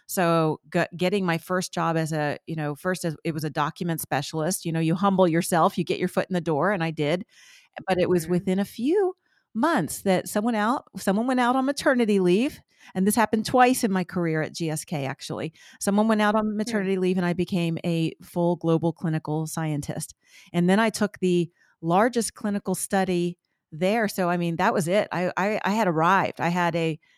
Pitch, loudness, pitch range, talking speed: 180 Hz, -25 LUFS, 165-205 Hz, 210 wpm